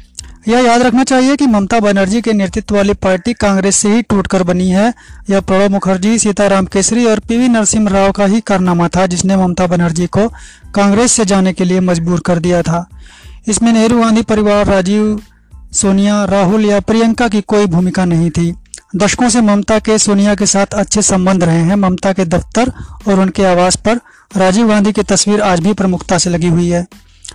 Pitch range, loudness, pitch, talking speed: 185-215 Hz, -11 LUFS, 200 Hz, 195 wpm